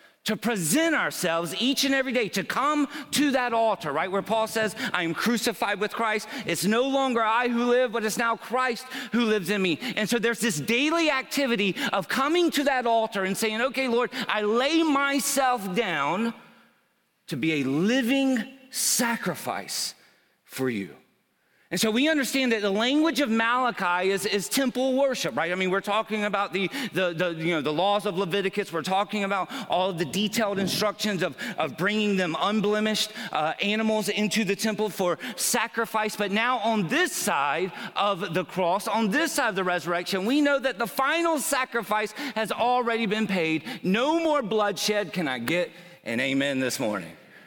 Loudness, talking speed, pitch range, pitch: -25 LUFS, 180 wpm, 195-250 Hz, 220 Hz